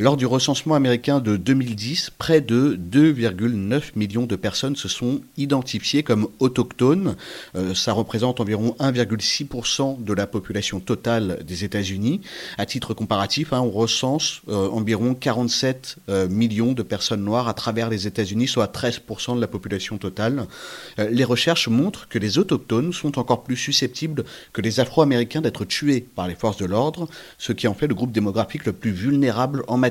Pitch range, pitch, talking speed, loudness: 110-135 Hz, 120 Hz, 170 wpm, -22 LUFS